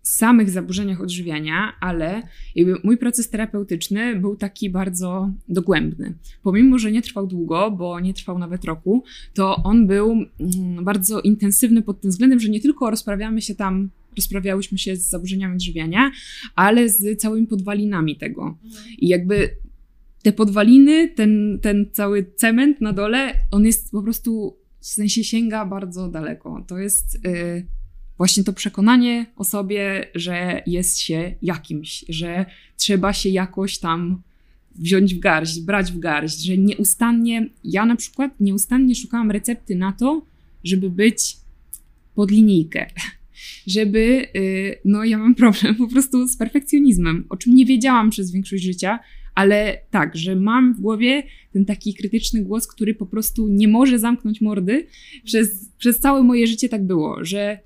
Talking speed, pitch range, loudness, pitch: 150 wpm, 190-230 Hz, -19 LUFS, 205 Hz